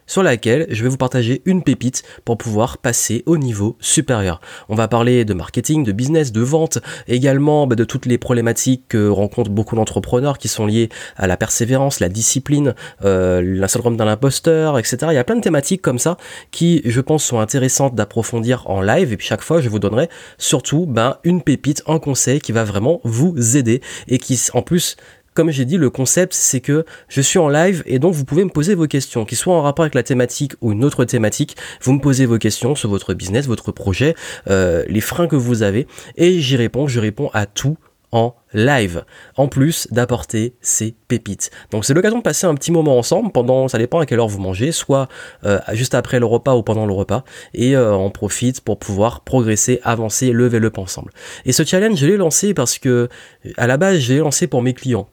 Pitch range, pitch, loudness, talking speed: 110-145 Hz, 125 Hz, -16 LUFS, 220 wpm